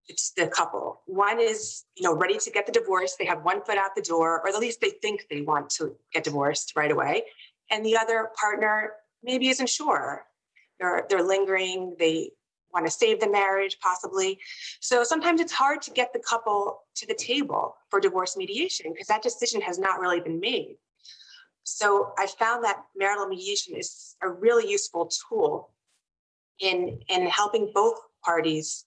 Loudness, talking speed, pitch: -26 LUFS, 180 wpm, 215 Hz